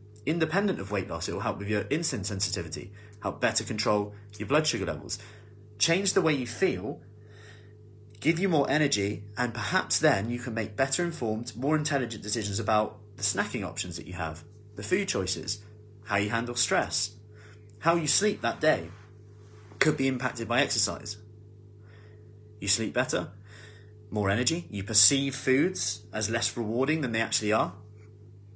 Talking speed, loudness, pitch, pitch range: 160 wpm, -28 LUFS, 105 Hz, 105-125 Hz